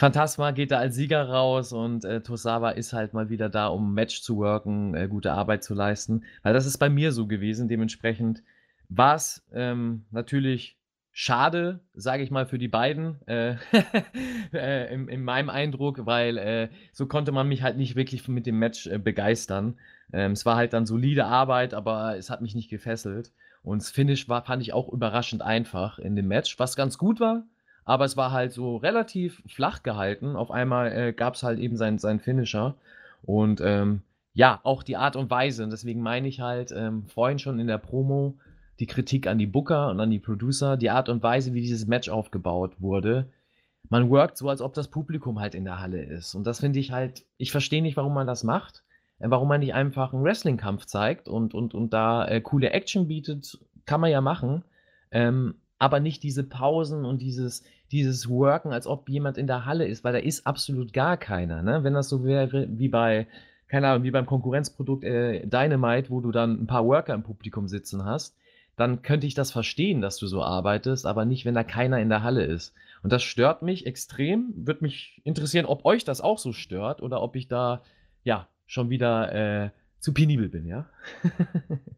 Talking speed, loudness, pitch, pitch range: 205 wpm, -26 LUFS, 125 Hz, 110-140 Hz